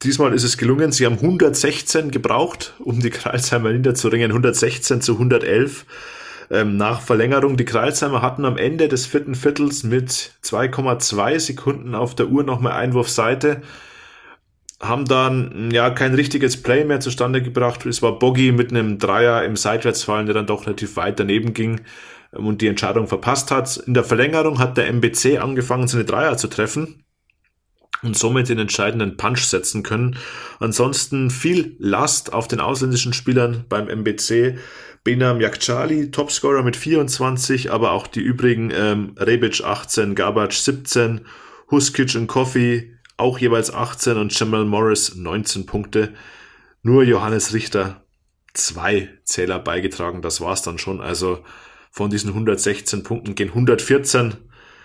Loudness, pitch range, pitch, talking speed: -19 LUFS, 110-130 Hz, 120 Hz, 145 wpm